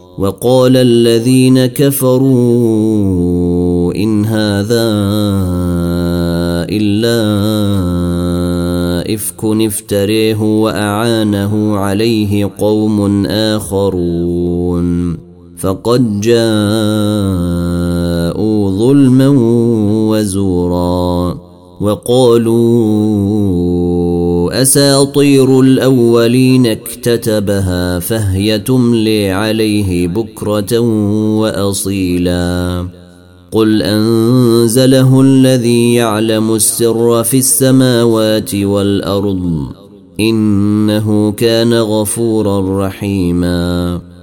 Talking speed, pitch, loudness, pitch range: 50 wpm, 105 Hz, -11 LUFS, 90-115 Hz